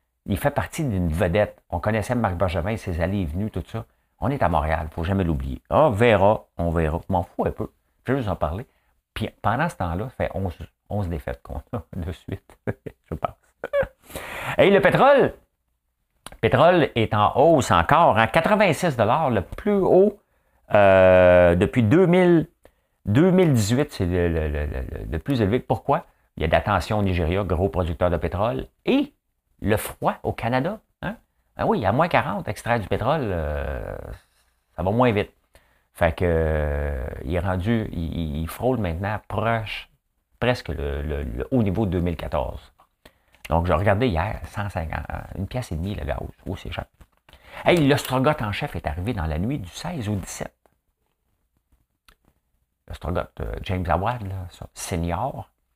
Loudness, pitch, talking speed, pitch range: -22 LUFS, 95 Hz, 175 wpm, 80-115 Hz